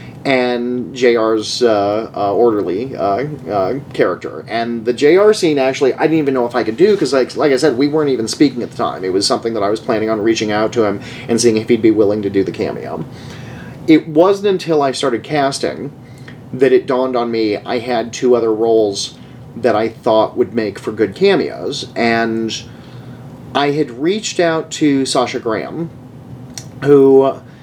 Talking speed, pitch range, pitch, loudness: 195 wpm, 115-140 Hz, 125 Hz, -15 LUFS